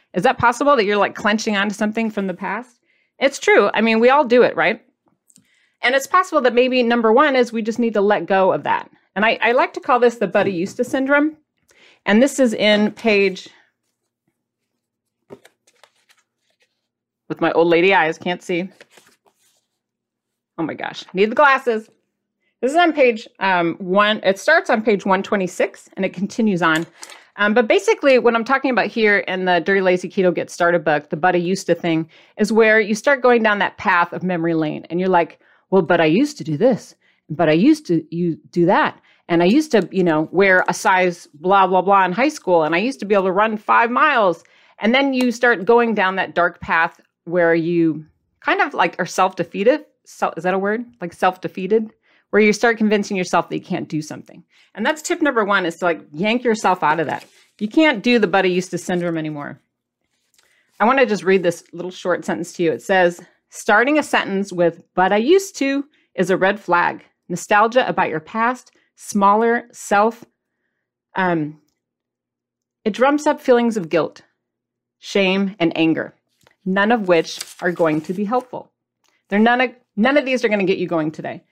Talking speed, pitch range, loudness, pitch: 200 wpm, 175-240 Hz, -17 LUFS, 195 Hz